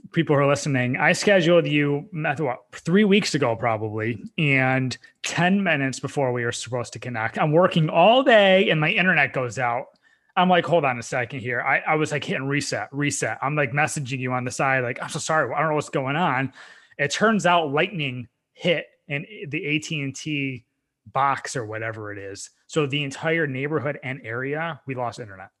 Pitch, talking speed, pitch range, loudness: 145 Hz, 195 wpm, 130-165 Hz, -22 LUFS